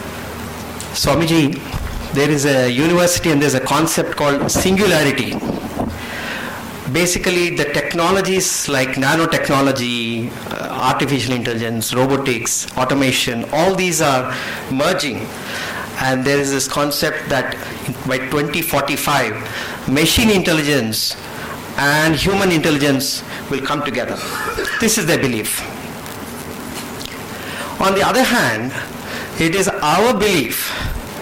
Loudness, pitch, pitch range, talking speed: -17 LUFS, 145 Hz, 130-170 Hz, 105 wpm